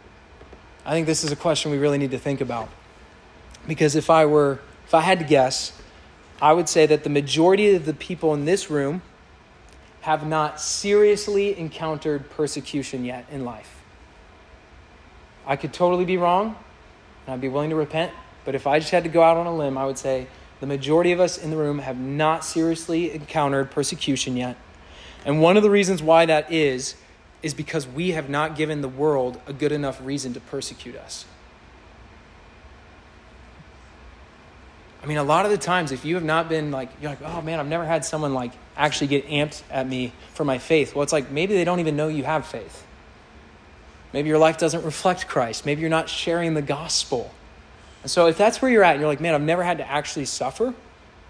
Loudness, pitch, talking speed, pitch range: -22 LUFS, 150 Hz, 200 wpm, 130-165 Hz